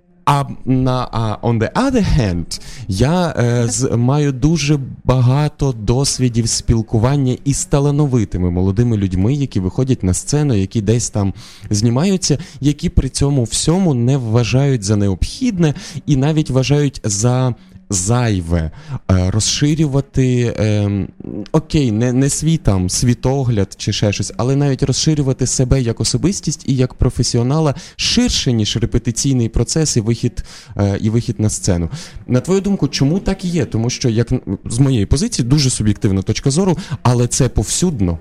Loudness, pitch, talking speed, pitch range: -16 LUFS, 125 Hz, 140 wpm, 110-145 Hz